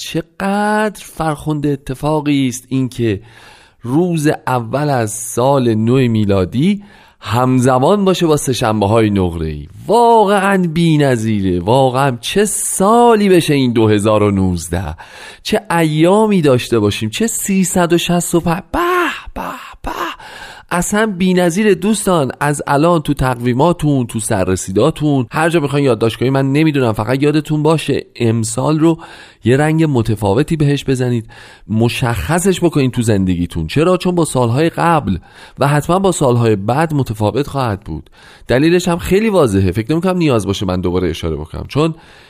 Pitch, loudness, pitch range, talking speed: 140 Hz, -14 LUFS, 115-170 Hz, 130 wpm